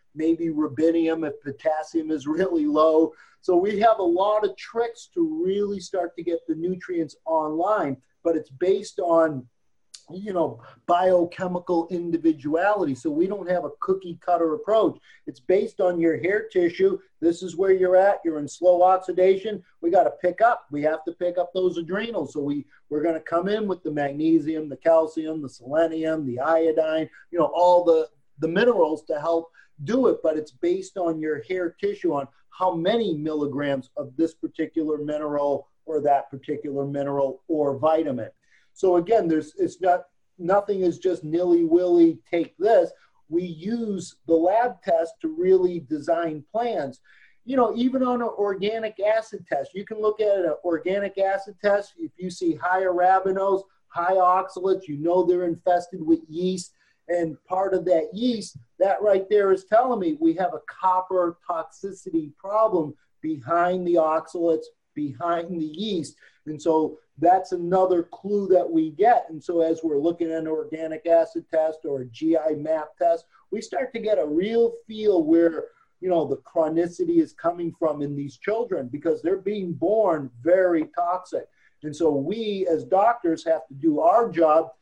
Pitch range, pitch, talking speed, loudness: 160-195 Hz, 175 Hz, 170 wpm, -24 LUFS